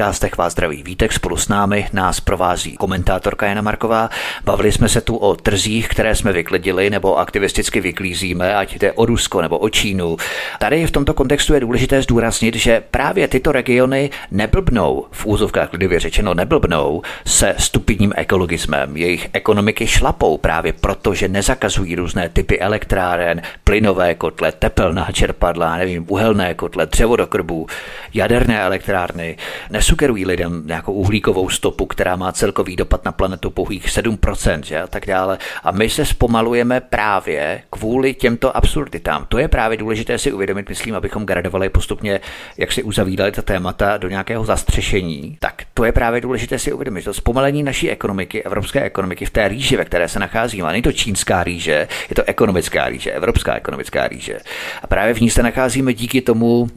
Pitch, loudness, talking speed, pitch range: 105 Hz, -17 LUFS, 165 wpm, 90-115 Hz